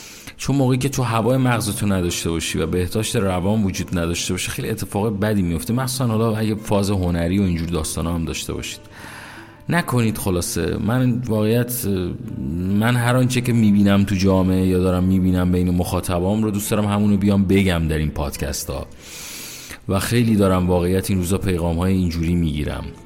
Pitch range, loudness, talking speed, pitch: 85-110 Hz, -20 LUFS, 170 wpm, 95 Hz